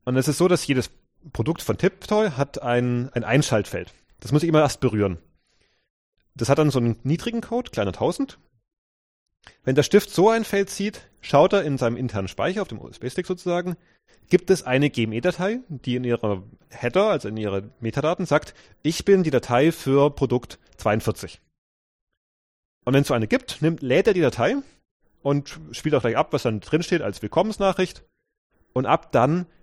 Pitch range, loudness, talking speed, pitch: 115-170 Hz, -23 LUFS, 180 wpm, 140 Hz